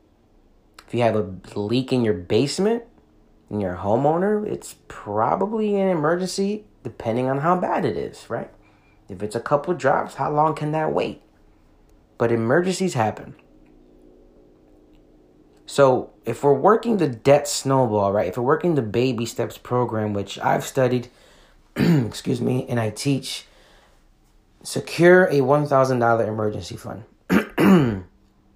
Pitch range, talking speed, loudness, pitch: 105-150 Hz, 140 wpm, -21 LUFS, 120 Hz